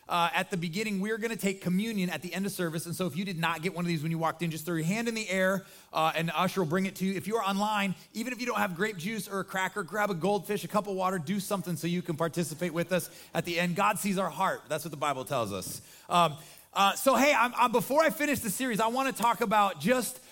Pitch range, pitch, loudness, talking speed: 170-210 Hz, 190 Hz, -30 LUFS, 305 wpm